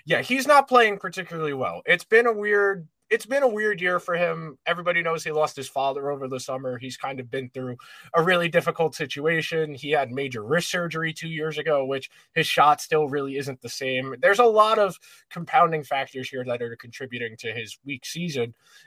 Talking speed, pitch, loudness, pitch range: 205 wpm, 155 Hz, -24 LUFS, 135-175 Hz